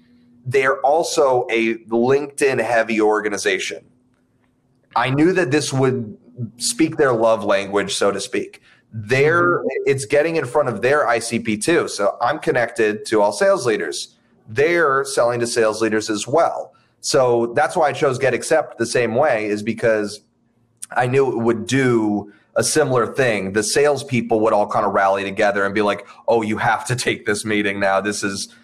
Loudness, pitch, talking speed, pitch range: -18 LUFS, 115 Hz, 170 wpm, 105-135 Hz